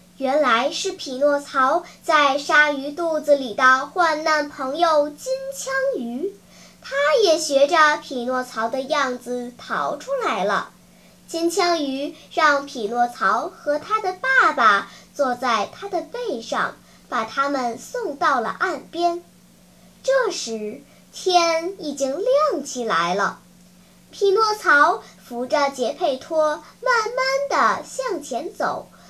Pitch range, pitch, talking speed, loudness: 265-345 Hz, 295 Hz, 170 characters per minute, -21 LUFS